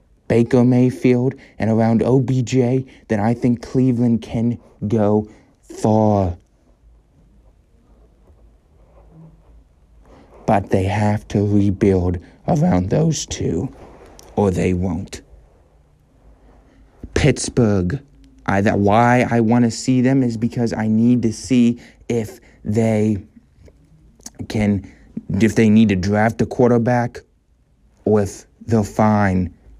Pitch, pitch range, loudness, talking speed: 110 Hz, 100-120 Hz, -18 LUFS, 105 wpm